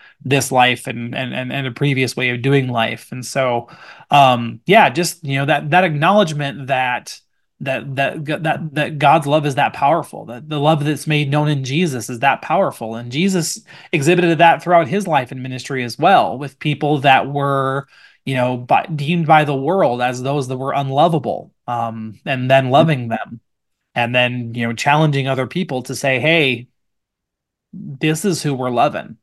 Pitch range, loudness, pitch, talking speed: 125-155 Hz, -17 LUFS, 140 Hz, 185 wpm